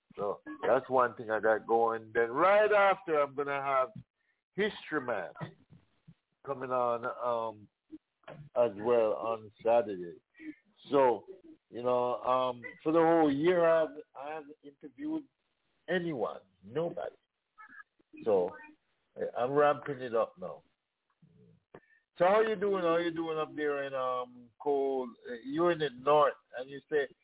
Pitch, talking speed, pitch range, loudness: 145 Hz, 145 wpm, 125-200 Hz, -31 LUFS